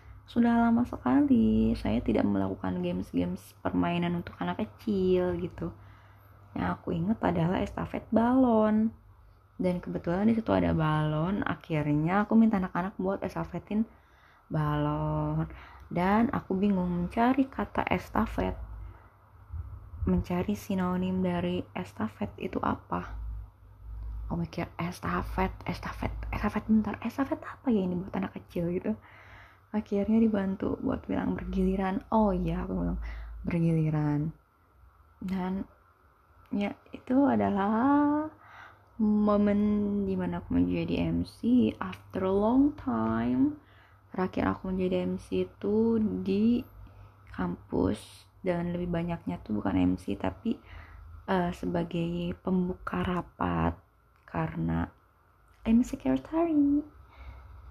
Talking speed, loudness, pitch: 105 wpm, -29 LUFS, 165 Hz